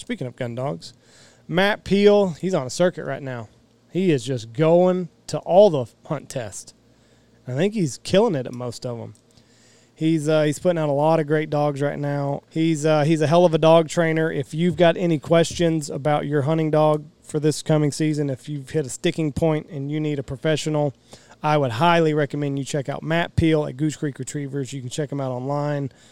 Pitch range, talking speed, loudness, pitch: 135-160 Hz, 215 wpm, -21 LUFS, 150 Hz